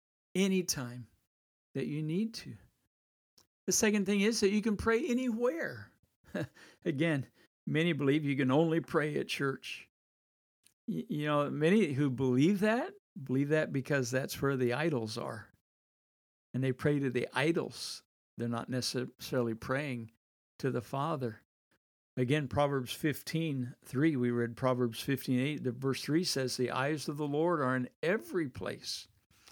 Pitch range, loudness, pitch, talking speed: 125-160 Hz, -33 LUFS, 135 Hz, 145 wpm